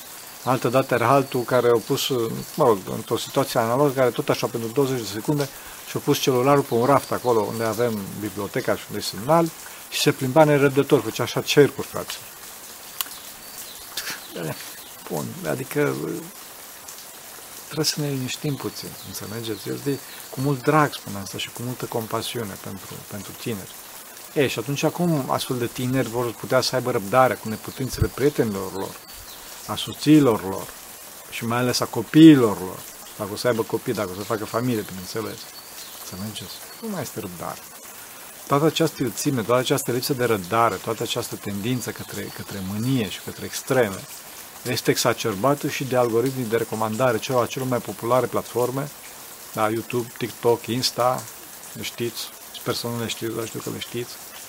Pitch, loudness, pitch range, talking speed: 120 Hz, -23 LUFS, 110-140 Hz, 165 wpm